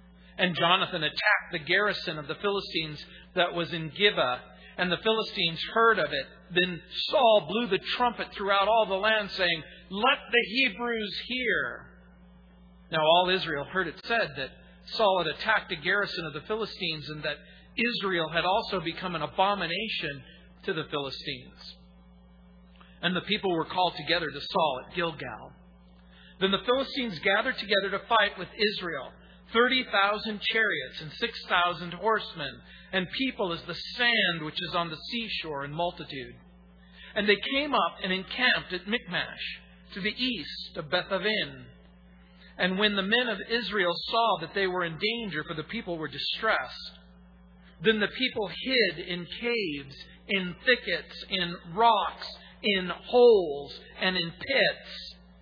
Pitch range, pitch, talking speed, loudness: 155-210 Hz, 180 Hz, 155 wpm, -27 LUFS